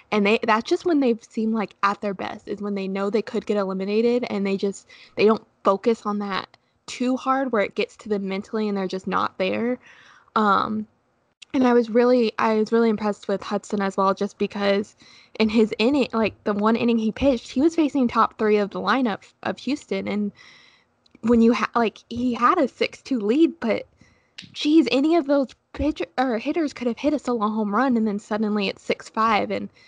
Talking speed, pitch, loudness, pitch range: 205 wpm, 220 Hz, -23 LUFS, 205-250 Hz